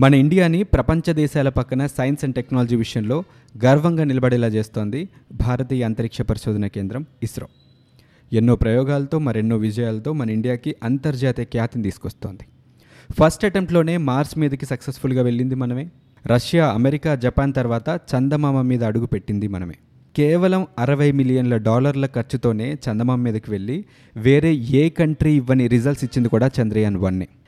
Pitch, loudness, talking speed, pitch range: 130 Hz, -20 LUFS, 130 wpm, 115-145 Hz